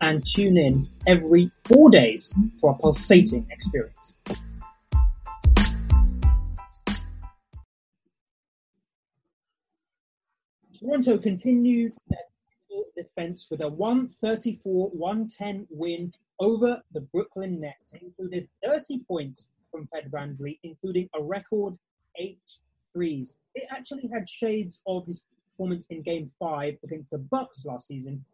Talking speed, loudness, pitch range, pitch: 105 wpm, -23 LUFS, 145-210 Hz, 175 Hz